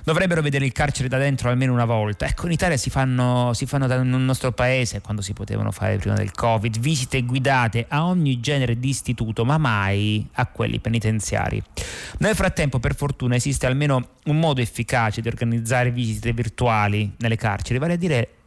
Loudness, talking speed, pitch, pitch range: -22 LUFS, 175 wpm, 125 Hz, 115-135 Hz